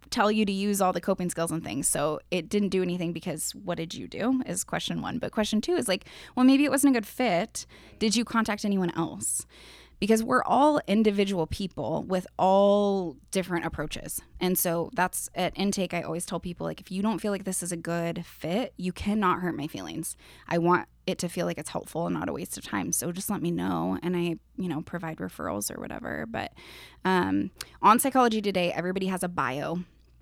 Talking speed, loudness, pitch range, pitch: 220 wpm, -28 LUFS, 170-205 Hz, 180 Hz